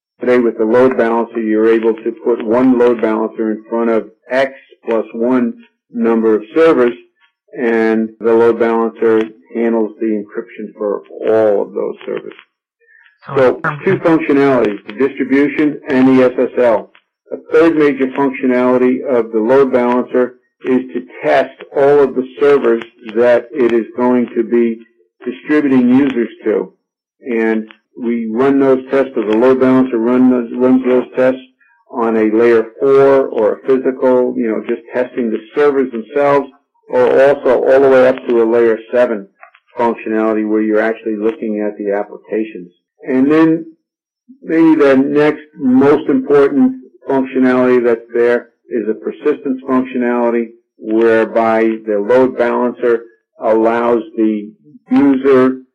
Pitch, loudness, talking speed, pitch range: 125 Hz, -13 LUFS, 140 wpm, 115-135 Hz